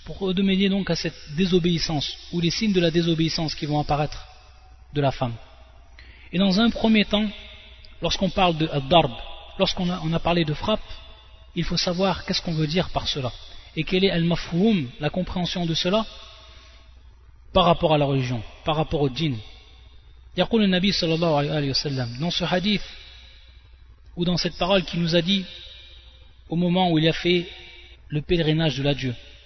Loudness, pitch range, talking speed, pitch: -23 LUFS, 135-180 Hz, 180 wpm, 165 Hz